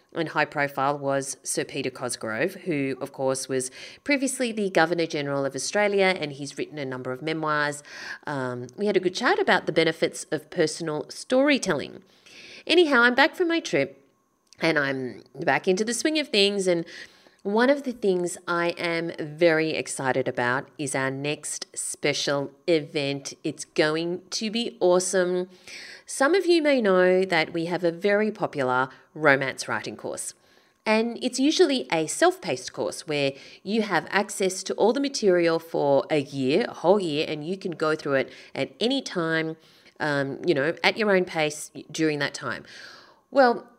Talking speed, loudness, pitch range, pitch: 170 wpm, -25 LUFS, 145-200 Hz, 165 Hz